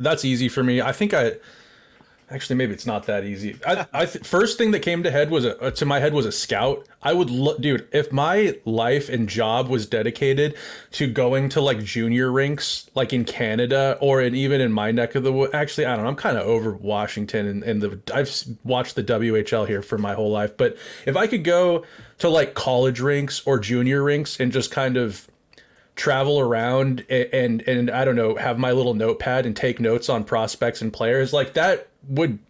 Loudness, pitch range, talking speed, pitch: -22 LUFS, 115-140 Hz, 220 wpm, 130 Hz